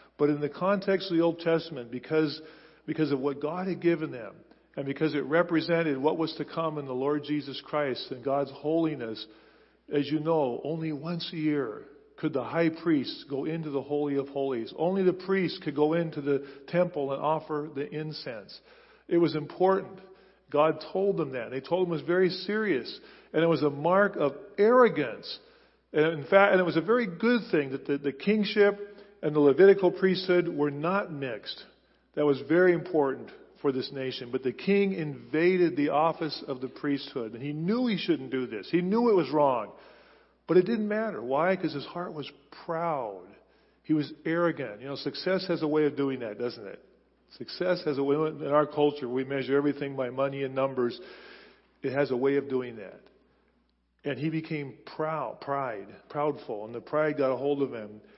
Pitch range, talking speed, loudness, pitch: 140-175 Hz, 195 wpm, -28 LUFS, 155 Hz